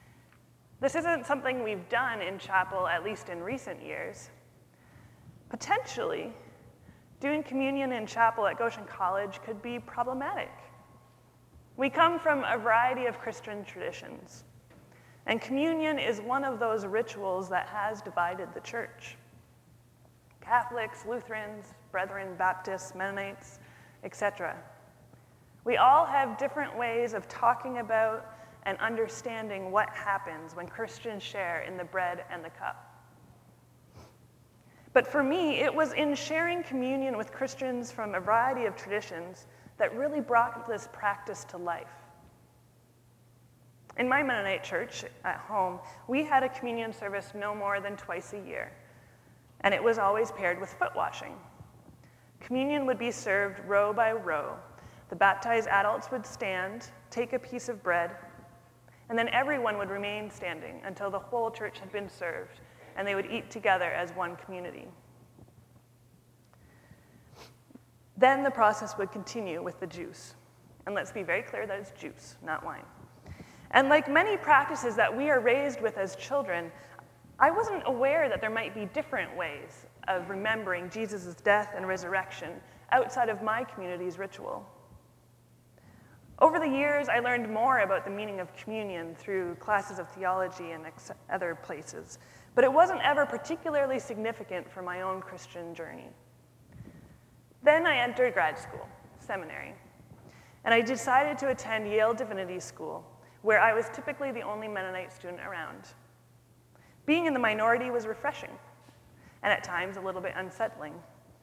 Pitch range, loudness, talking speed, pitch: 185-250 Hz, -30 LUFS, 145 wpm, 210 Hz